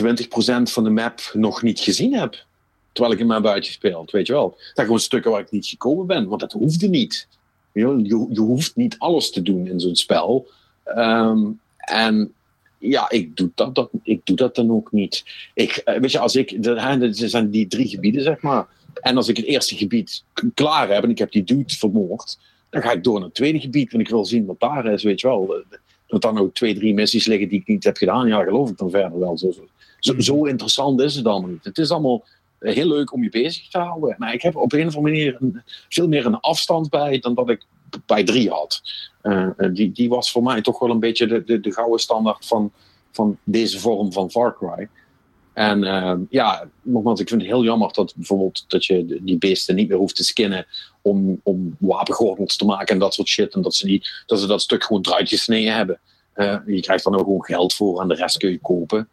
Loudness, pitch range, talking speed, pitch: -19 LUFS, 100-130 Hz, 230 wpm, 115 Hz